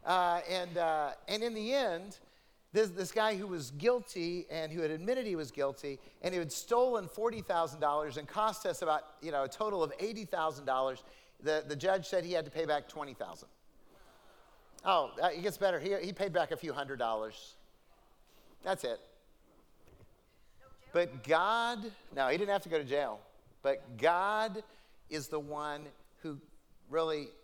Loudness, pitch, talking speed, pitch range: -35 LUFS, 165 Hz, 165 wpm, 150-200 Hz